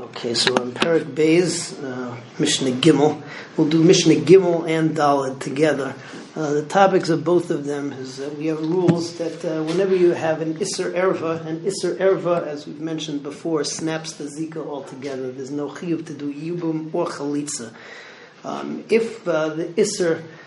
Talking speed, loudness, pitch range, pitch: 170 wpm, -21 LUFS, 145-170 Hz, 160 Hz